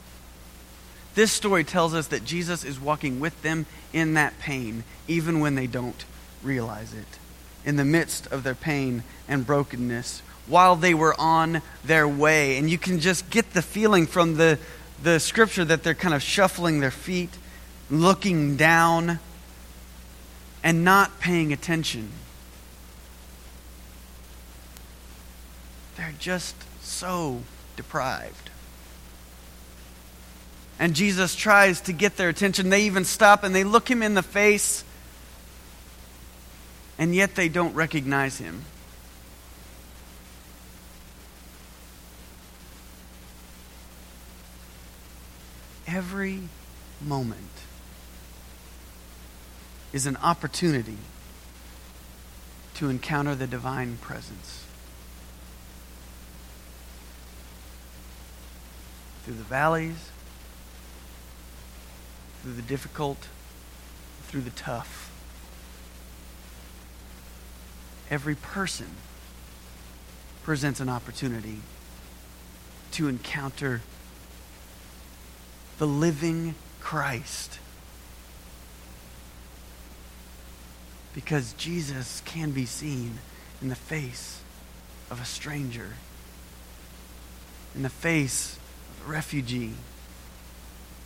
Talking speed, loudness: 85 wpm, -24 LUFS